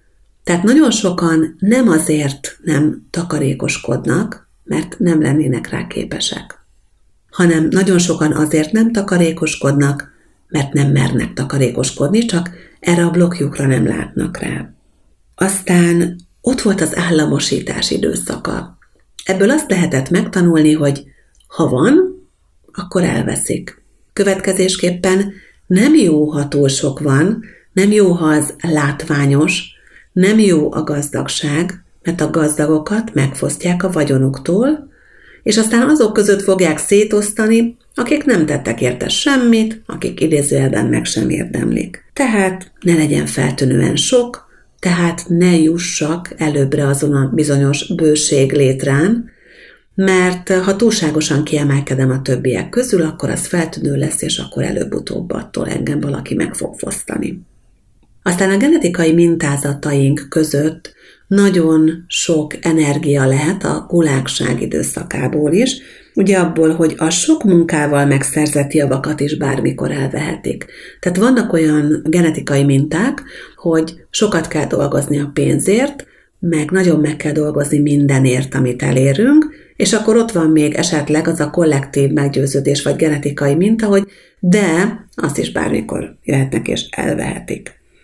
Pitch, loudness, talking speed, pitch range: 160 Hz, -15 LUFS, 125 wpm, 145-190 Hz